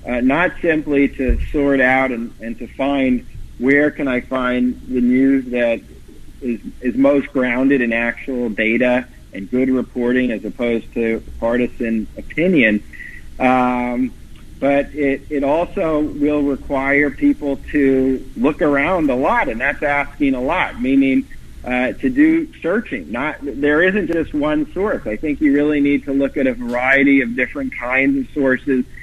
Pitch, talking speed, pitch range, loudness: 130 Hz, 155 wpm, 125-145 Hz, -17 LUFS